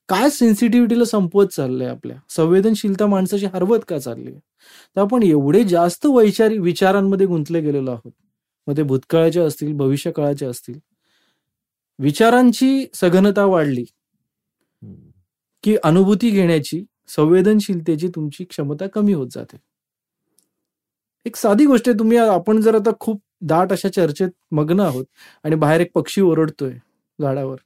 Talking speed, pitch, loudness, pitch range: 130 wpm, 180 Hz, -17 LUFS, 150-210 Hz